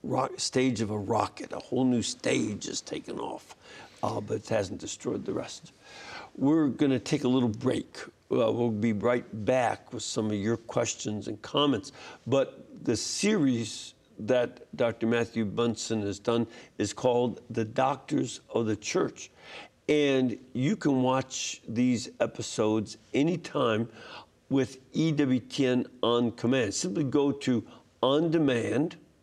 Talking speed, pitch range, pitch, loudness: 145 wpm, 115-130 Hz, 120 Hz, -29 LUFS